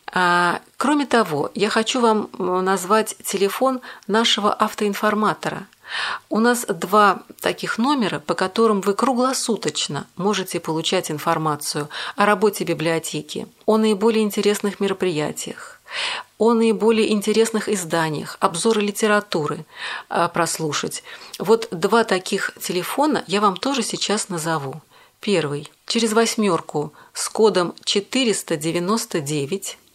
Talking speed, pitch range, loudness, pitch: 100 wpm, 175-225 Hz, -20 LUFS, 205 Hz